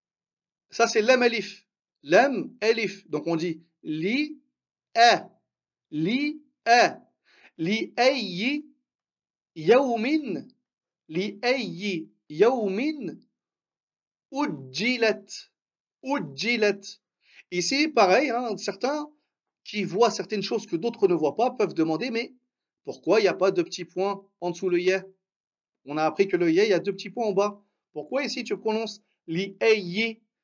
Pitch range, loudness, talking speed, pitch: 190-250 Hz, -25 LUFS, 130 wpm, 215 Hz